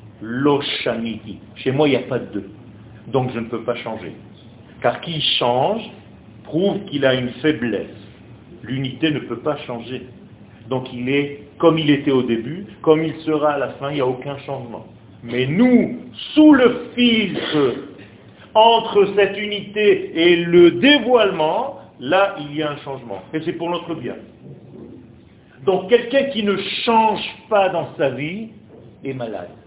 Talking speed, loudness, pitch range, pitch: 160 wpm, -18 LUFS, 120-195 Hz, 145 Hz